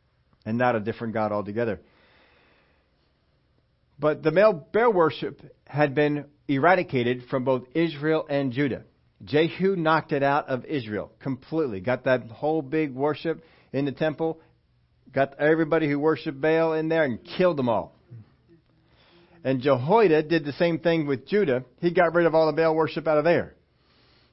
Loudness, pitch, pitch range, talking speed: -24 LUFS, 150 Hz, 125-160 Hz, 160 wpm